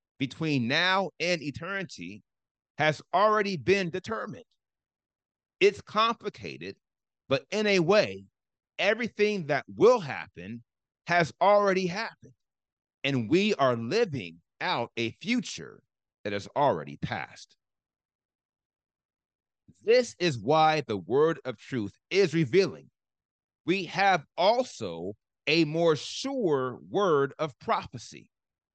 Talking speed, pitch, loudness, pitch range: 105 wpm, 165 Hz, -27 LUFS, 130-195 Hz